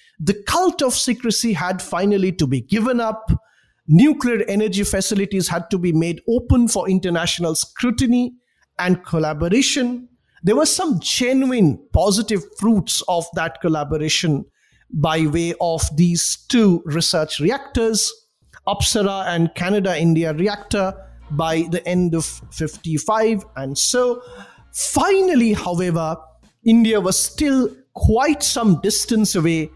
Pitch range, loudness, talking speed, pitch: 165-230 Hz, -18 LUFS, 120 wpm, 195 Hz